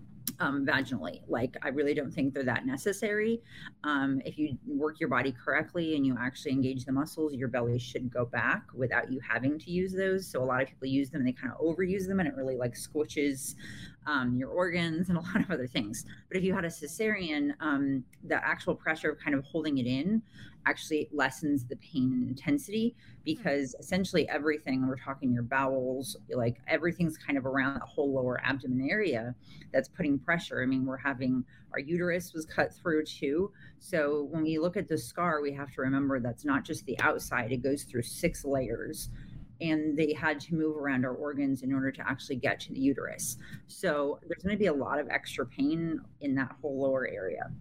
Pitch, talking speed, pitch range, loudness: 145 Hz, 210 wpm, 130-160 Hz, -32 LUFS